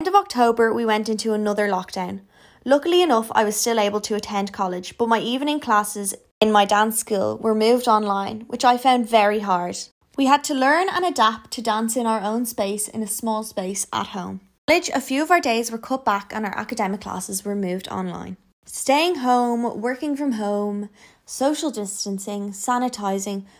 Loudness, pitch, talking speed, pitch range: -21 LUFS, 220 Hz, 190 wpm, 205-245 Hz